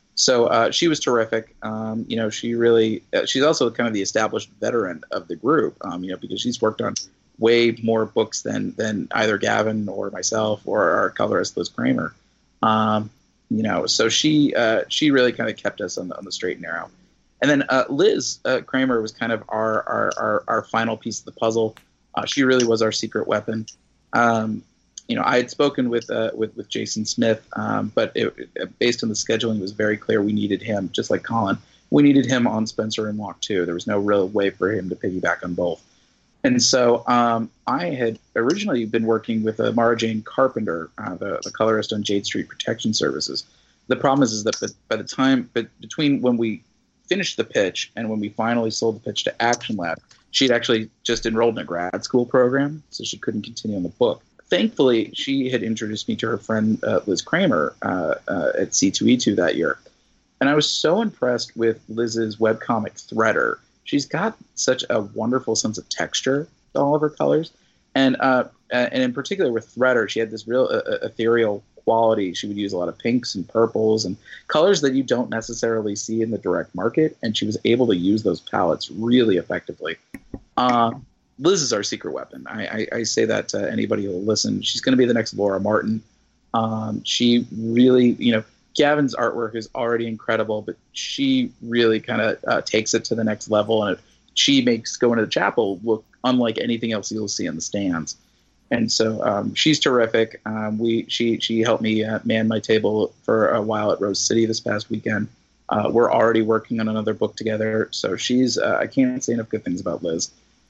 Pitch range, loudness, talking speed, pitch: 110-120 Hz, -21 LUFS, 210 wpm, 115 Hz